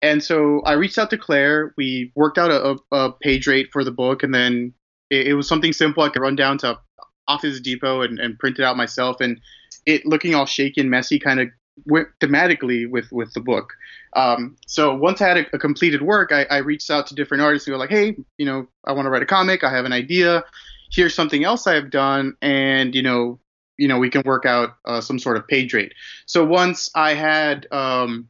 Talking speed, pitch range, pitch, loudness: 230 wpm, 130-155 Hz, 140 Hz, -19 LUFS